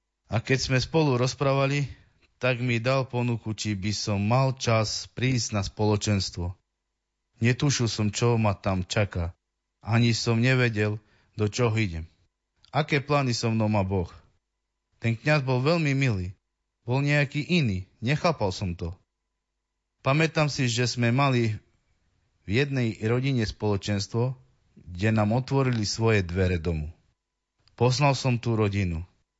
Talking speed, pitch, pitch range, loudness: 135 wpm, 110 Hz, 95-125 Hz, -26 LUFS